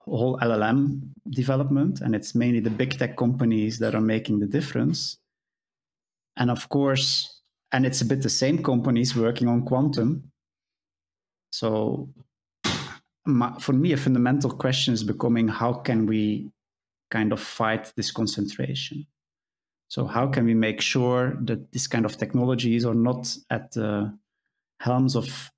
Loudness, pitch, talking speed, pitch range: -25 LUFS, 120 Hz, 145 wpm, 110-130 Hz